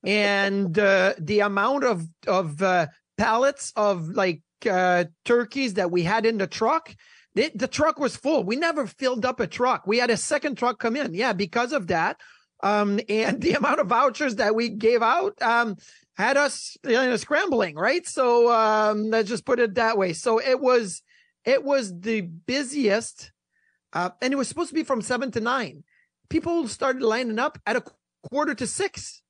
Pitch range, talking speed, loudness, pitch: 205-270 Hz, 190 wpm, -23 LUFS, 235 Hz